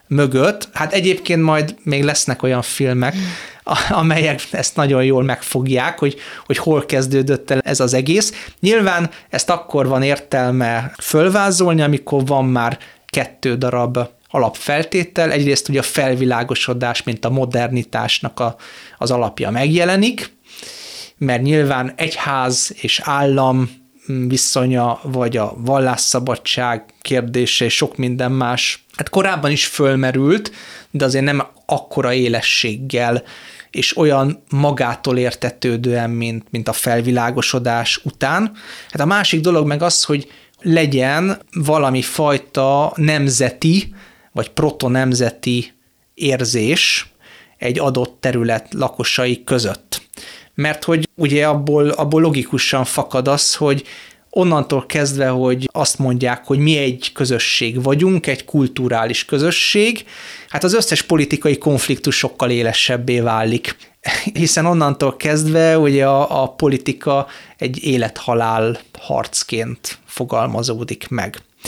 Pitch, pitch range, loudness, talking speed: 135 Hz, 125-150 Hz, -16 LUFS, 115 wpm